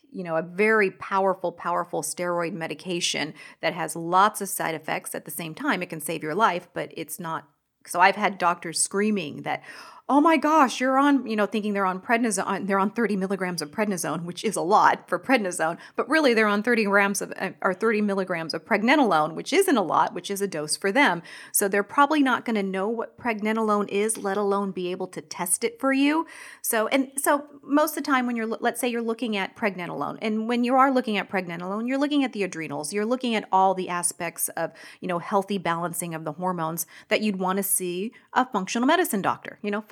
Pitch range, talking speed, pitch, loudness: 175-235 Hz, 220 wpm, 200 Hz, -24 LUFS